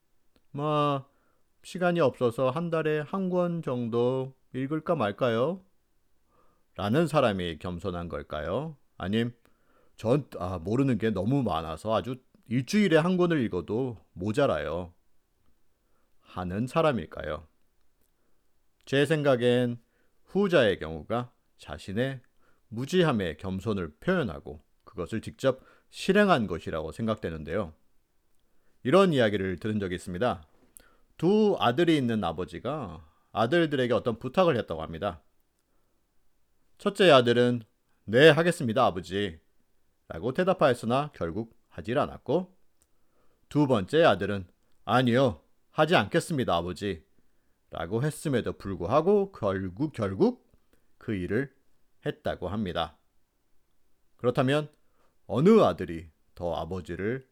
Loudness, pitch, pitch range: -27 LUFS, 120 Hz, 95-150 Hz